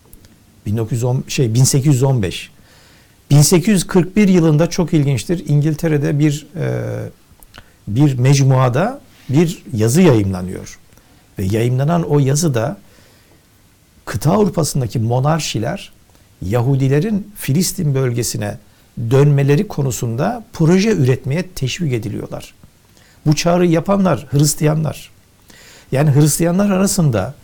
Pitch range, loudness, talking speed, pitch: 110-160 Hz, -16 LUFS, 85 wpm, 140 Hz